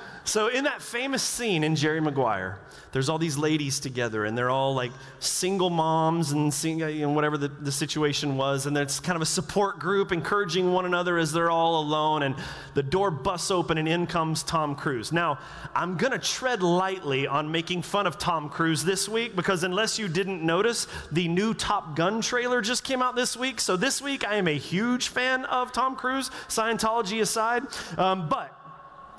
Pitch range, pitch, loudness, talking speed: 150-210 Hz, 170 Hz, -26 LUFS, 195 wpm